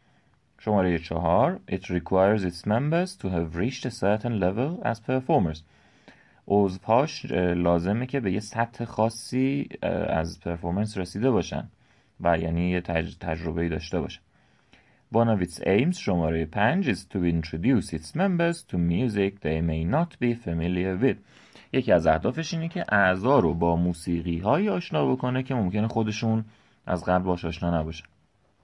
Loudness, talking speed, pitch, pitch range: -26 LUFS, 150 wpm, 100 Hz, 85-125 Hz